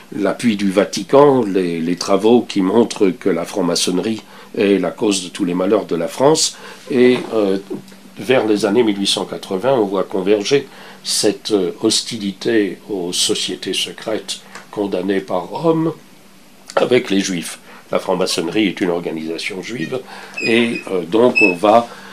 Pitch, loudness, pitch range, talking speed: 105 Hz, -17 LUFS, 95-125 Hz, 140 wpm